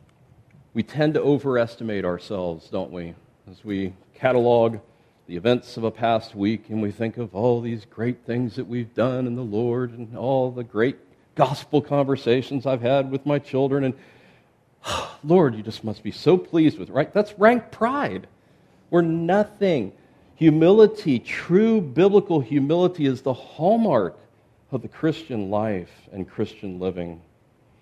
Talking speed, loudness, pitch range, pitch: 155 wpm, -22 LUFS, 110-145 Hz, 125 Hz